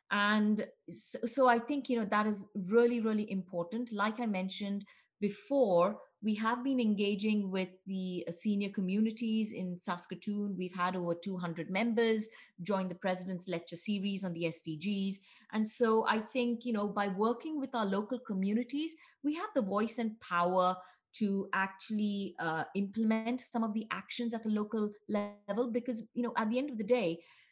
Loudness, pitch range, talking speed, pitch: -34 LUFS, 190-230 Hz, 170 wpm, 210 Hz